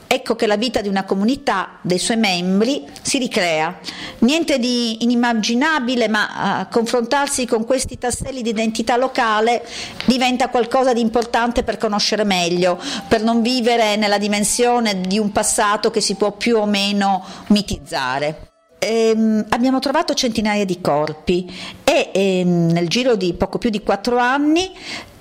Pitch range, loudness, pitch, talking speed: 205-250 Hz, -18 LUFS, 225 Hz, 145 wpm